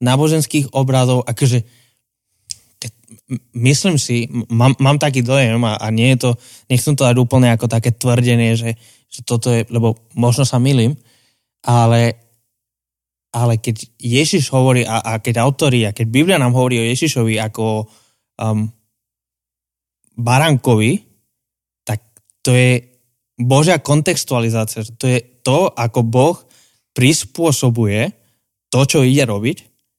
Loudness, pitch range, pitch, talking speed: -15 LUFS, 115-130 Hz, 120 Hz, 125 wpm